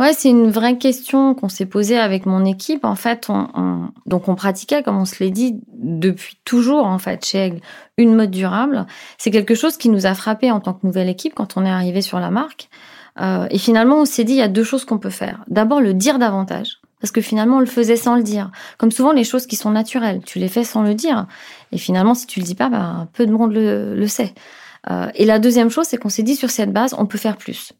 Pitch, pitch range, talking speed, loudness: 220 Hz, 195-245 Hz, 260 wpm, -17 LUFS